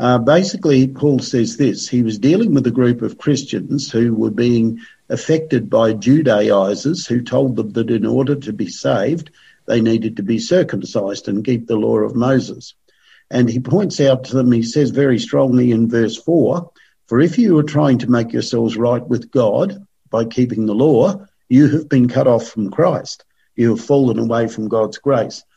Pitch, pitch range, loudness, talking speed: 125 Hz, 115-140 Hz, -16 LUFS, 190 wpm